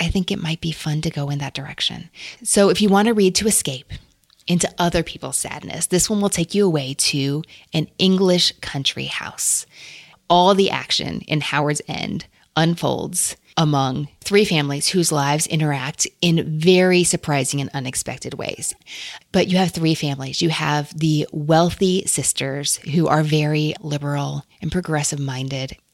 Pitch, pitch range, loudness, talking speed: 160 Hz, 145-175 Hz, -19 LUFS, 160 wpm